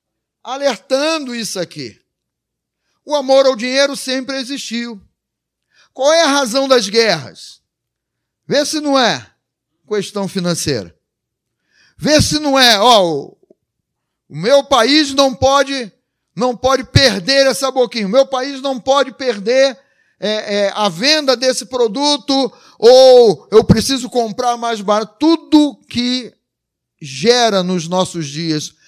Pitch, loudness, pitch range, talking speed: 255 Hz, -14 LUFS, 215-275 Hz, 125 wpm